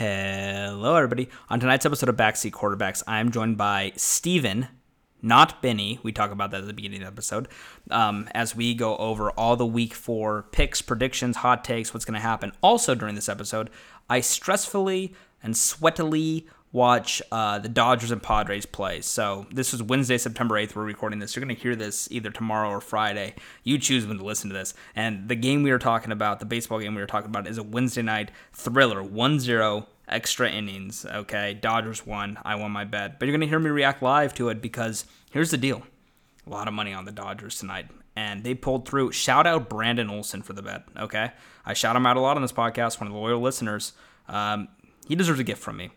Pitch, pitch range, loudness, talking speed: 115 Hz, 105-125 Hz, -25 LUFS, 215 wpm